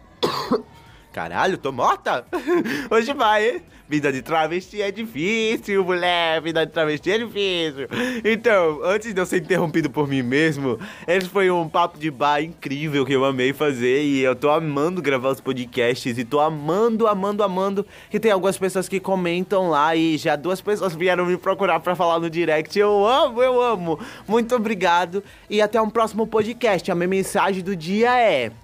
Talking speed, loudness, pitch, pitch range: 175 wpm, -21 LUFS, 180 Hz, 155-210 Hz